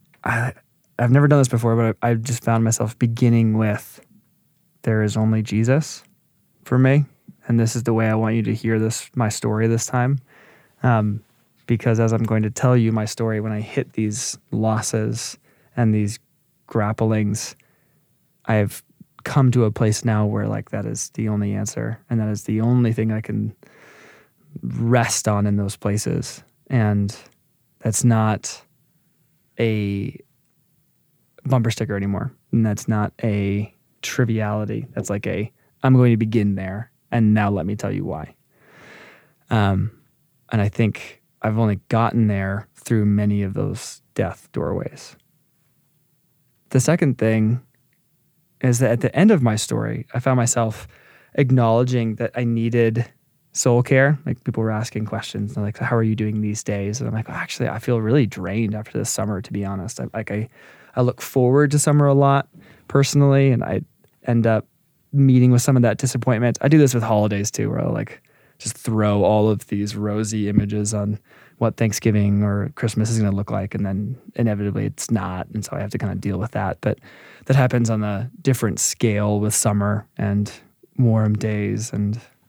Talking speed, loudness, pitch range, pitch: 175 wpm, -21 LUFS, 105-130 Hz, 115 Hz